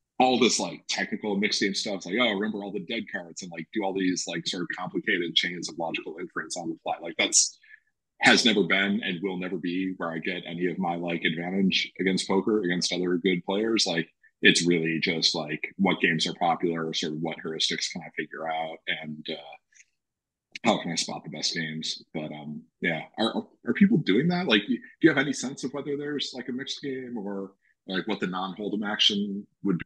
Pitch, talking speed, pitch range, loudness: 95 Hz, 220 wpm, 85-135 Hz, -26 LUFS